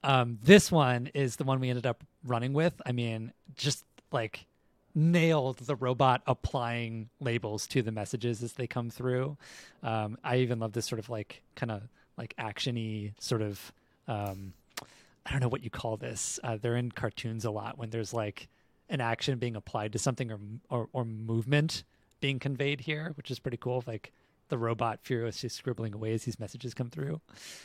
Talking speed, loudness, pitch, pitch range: 185 wpm, -32 LUFS, 120 Hz, 115-135 Hz